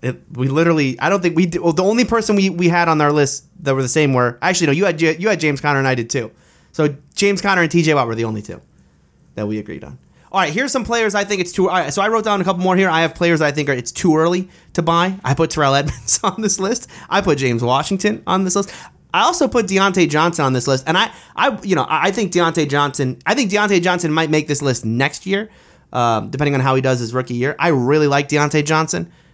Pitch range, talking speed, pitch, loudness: 135-190 Hz, 270 wpm, 160 Hz, -17 LUFS